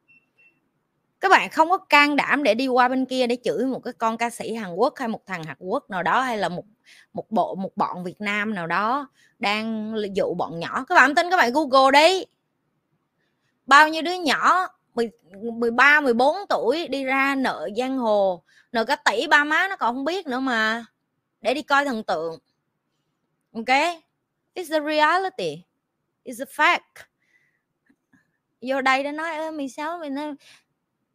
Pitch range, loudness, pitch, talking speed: 225-305 Hz, -21 LUFS, 260 Hz, 175 wpm